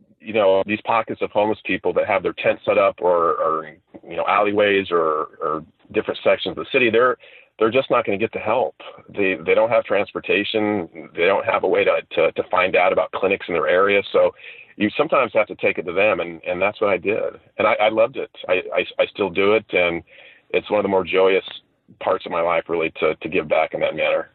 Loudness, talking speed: -20 LUFS, 245 wpm